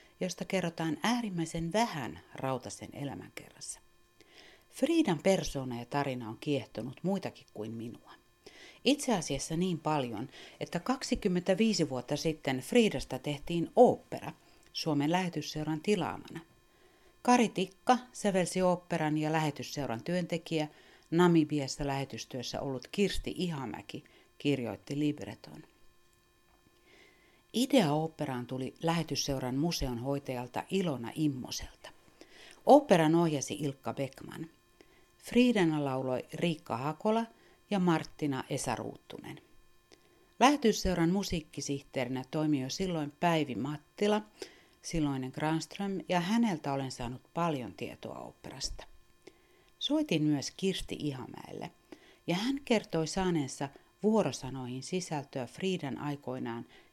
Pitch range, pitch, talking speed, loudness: 135-190 Hz, 155 Hz, 95 wpm, -32 LUFS